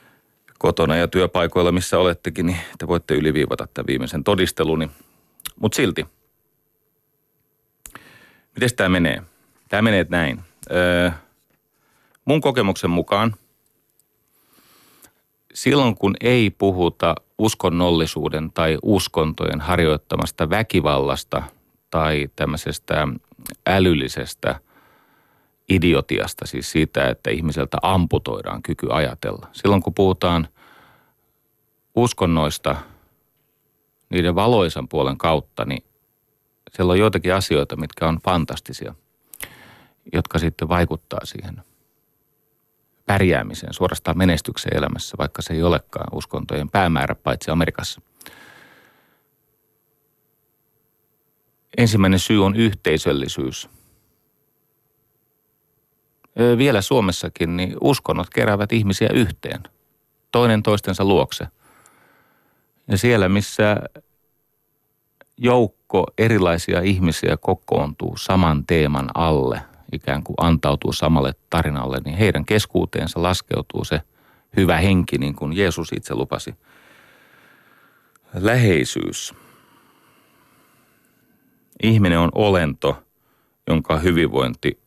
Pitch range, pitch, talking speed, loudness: 80-110 Hz, 90 Hz, 90 wpm, -20 LUFS